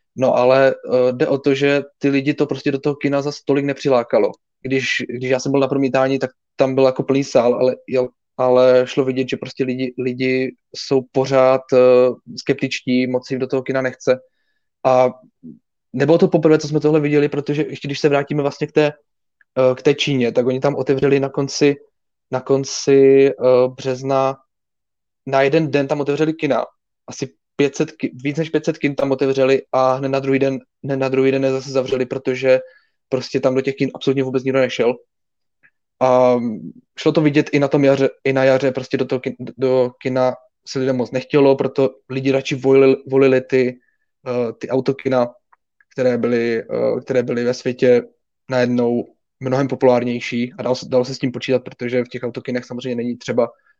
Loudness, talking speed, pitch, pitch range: -18 LUFS, 185 wpm, 135 Hz, 130-140 Hz